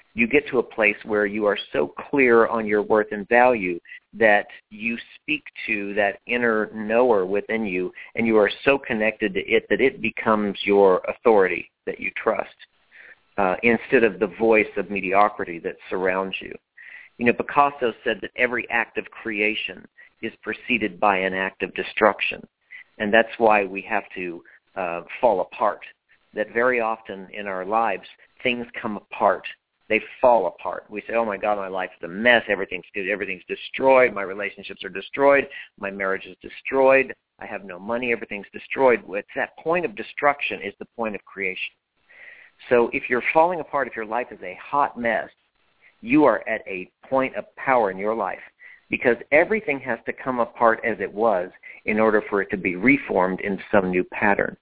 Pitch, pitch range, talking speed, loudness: 110 Hz, 100-120 Hz, 180 wpm, -22 LUFS